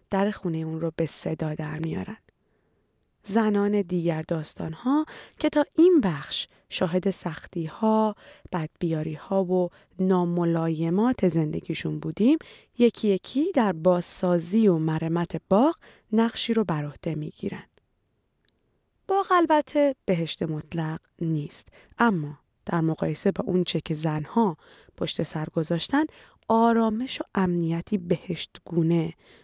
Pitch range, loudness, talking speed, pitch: 165-220 Hz, -26 LUFS, 120 wpm, 180 Hz